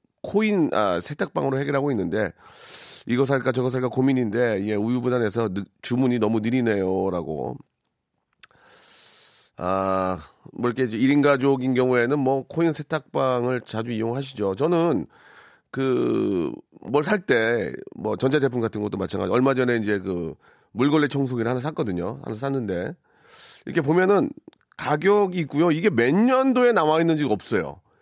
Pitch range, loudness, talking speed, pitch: 115-155 Hz, -23 LUFS, 305 characters per minute, 130 Hz